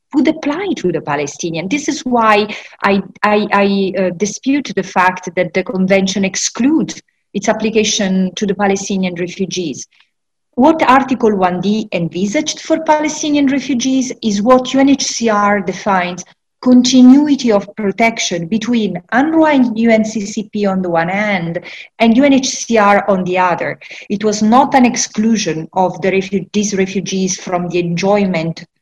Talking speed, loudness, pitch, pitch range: 135 wpm, -14 LUFS, 205 Hz, 190-250 Hz